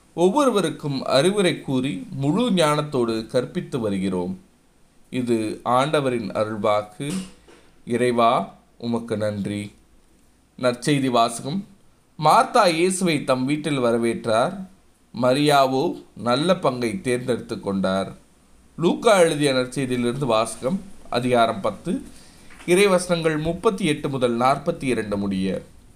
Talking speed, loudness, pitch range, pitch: 90 wpm, -22 LUFS, 115-160 Hz, 130 Hz